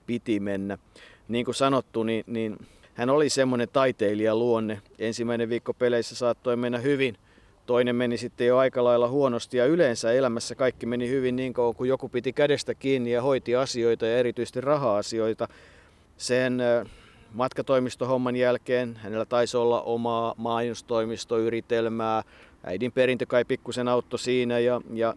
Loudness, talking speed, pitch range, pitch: -26 LUFS, 140 wpm, 115-125 Hz, 120 Hz